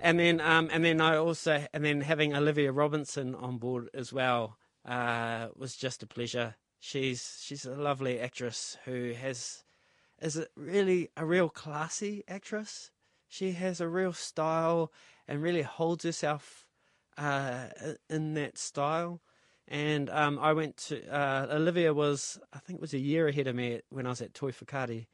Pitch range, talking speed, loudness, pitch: 130-160 Hz, 170 wpm, -32 LUFS, 145 Hz